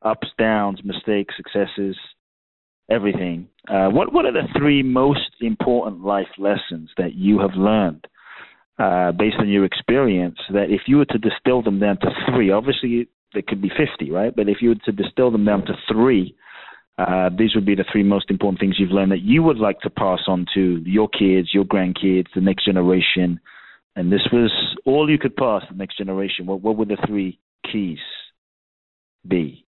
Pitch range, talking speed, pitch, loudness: 95-110 Hz, 190 wpm, 100 Hz, -19 LUFS